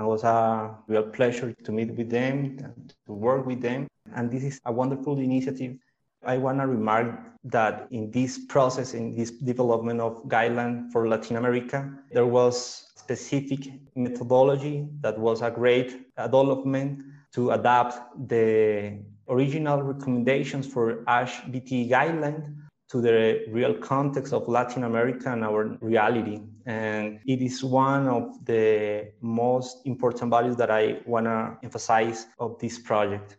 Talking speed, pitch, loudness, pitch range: 145 wpm, 120 Hz, -26 LUFS, 115-130 Hz